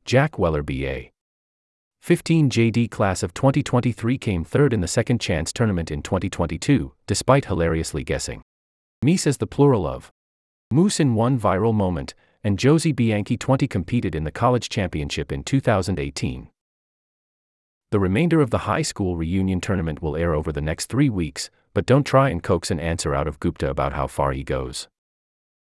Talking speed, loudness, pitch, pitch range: 165 wpm, -22 LUFS, 100 Hz, 80-125 Hz